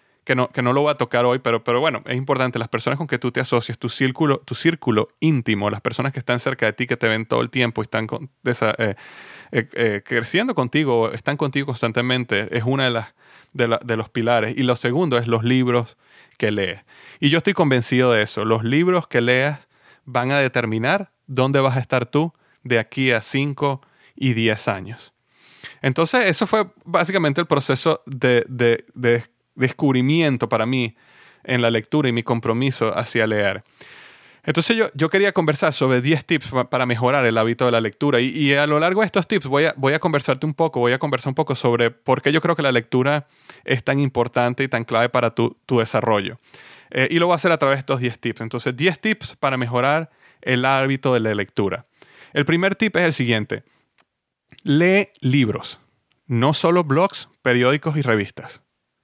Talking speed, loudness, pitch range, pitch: 205 wpm, -20 LUFS, 120-150 Hz, 130 Hz